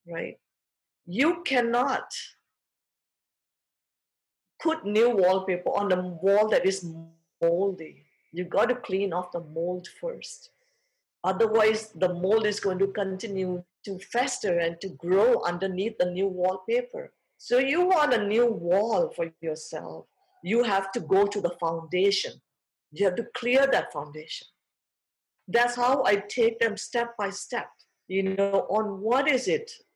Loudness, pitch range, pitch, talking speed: -26 LUFS, 180-245 Hz, 200 Hz, 140 wpm